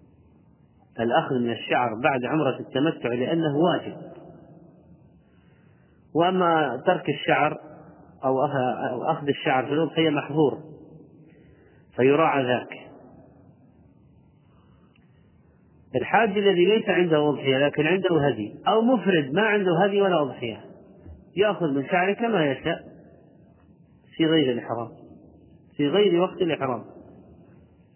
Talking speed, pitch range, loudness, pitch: 100 wpm, 140-180 Hz, -23 LUFS, 160 Hz